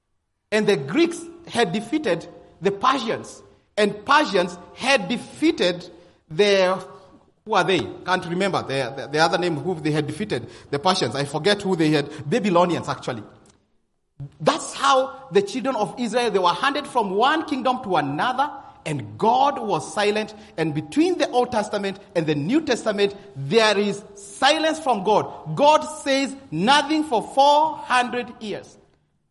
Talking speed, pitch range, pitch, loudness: 150 wpm, 175-260 Hz, 205 Hz, -22 LUFS